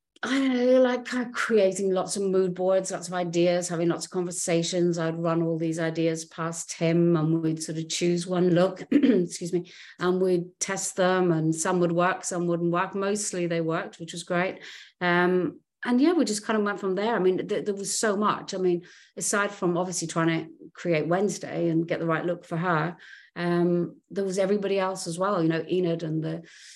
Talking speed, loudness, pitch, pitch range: 215 wpm, -26 LUFS, 180 Hz, 170-195 Hz